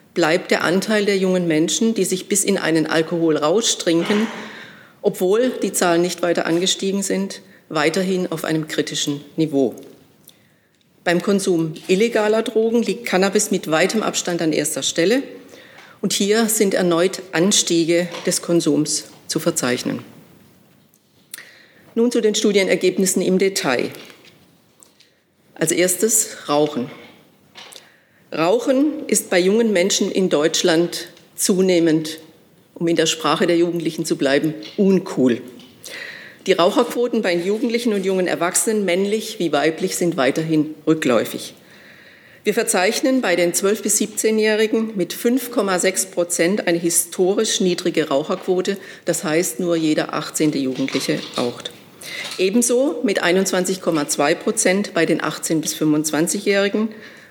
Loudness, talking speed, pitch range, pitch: -19 LUFS, 120 wpm, 165-210 Hz, 180 Hz